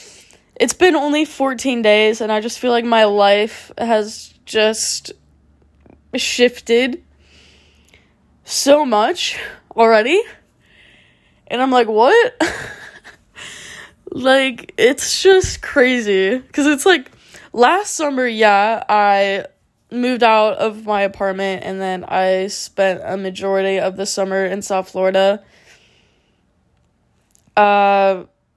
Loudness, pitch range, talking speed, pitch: -16 LUFS, 195-265 Hz, 105 wpm, 220 Hz